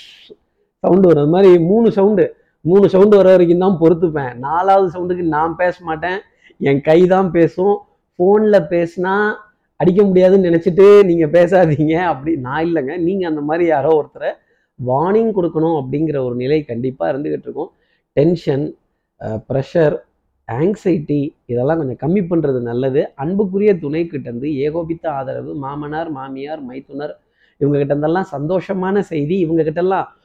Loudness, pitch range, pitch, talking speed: -15 LUFS, 150-190 Hz, 165 Hz, 125 wpm